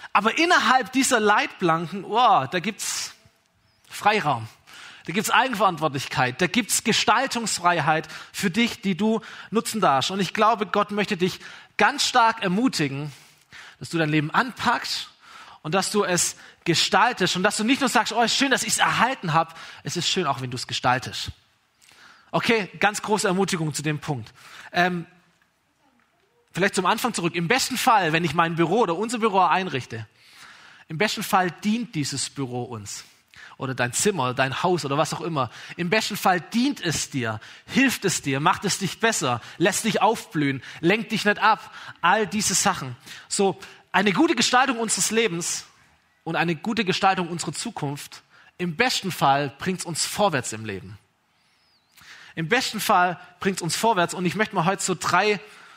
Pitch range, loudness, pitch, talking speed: 155-215 Hz, -23 LUFS, 185 Hz, 170 wpm